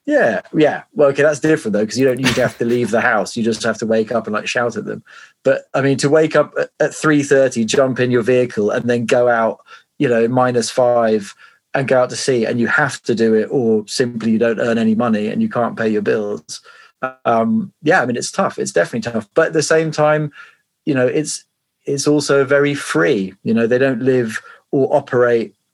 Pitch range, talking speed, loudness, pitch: 115-140 Hz, 235 wpm, -16 LUFS, 125 Hz